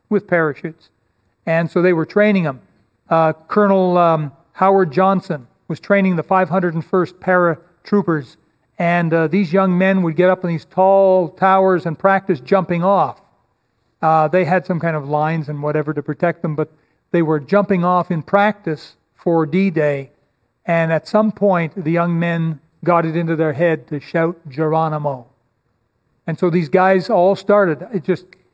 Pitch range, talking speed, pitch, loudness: 155-185 Hz, 165 wpm, 170 Hz, -17 LUFS